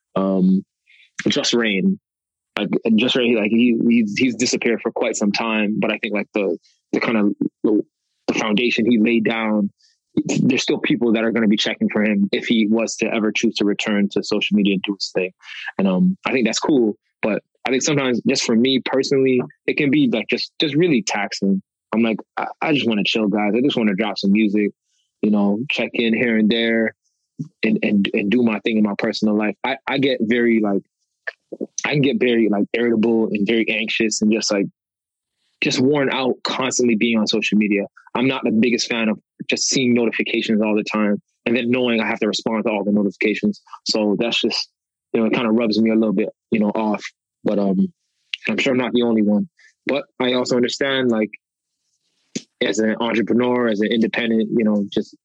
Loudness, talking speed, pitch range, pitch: -19 LUFS, 215 wpm, 105-120 Hz, 110 Hz